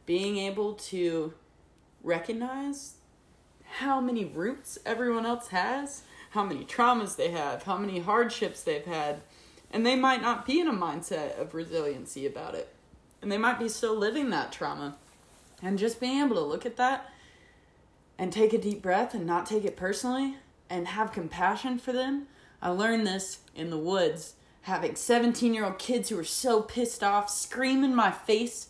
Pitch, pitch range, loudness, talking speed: 220 Hz, 185-250 Hz, -29 LUFS, 175 wpm